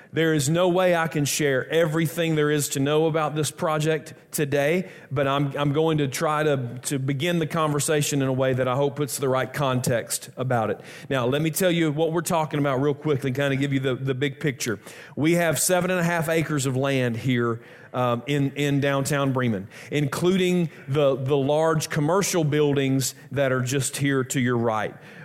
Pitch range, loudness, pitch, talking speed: 135-160 Hz, -23 LUFS, 145 Hz, 205 wpm